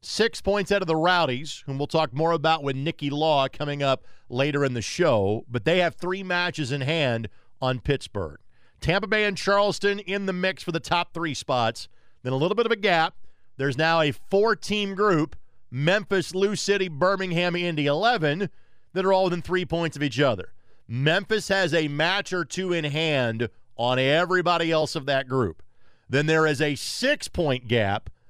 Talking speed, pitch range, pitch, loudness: 190 wpm, 135-185 Hz, 160 Hz, -24 LUFS